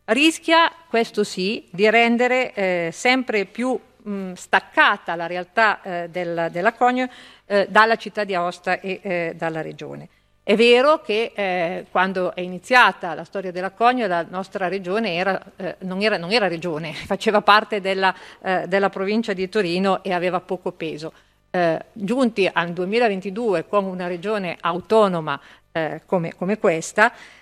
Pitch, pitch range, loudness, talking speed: 195 Hz, 180-220 Hz, -21 LUFS, 155 wpm